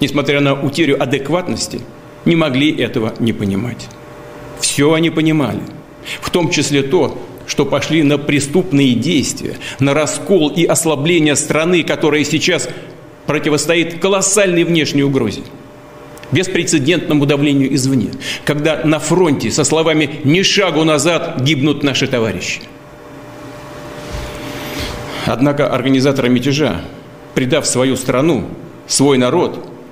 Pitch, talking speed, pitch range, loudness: 150 Hz, 110 wpm, 135-160 Hz, -14 LUFS